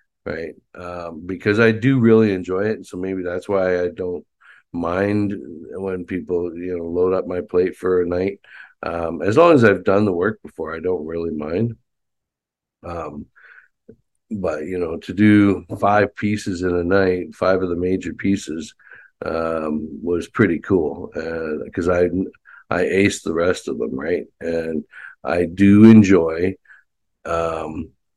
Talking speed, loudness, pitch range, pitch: 160 wpm, -19 LUFS, 85-100 Hz, 90 Hz